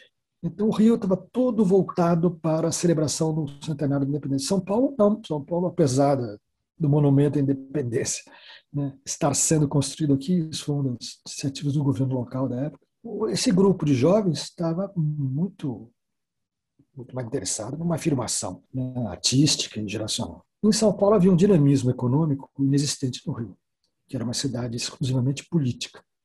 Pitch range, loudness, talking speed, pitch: 130-170 Hz, -24 LUFS, 155 wpm, 145 Hz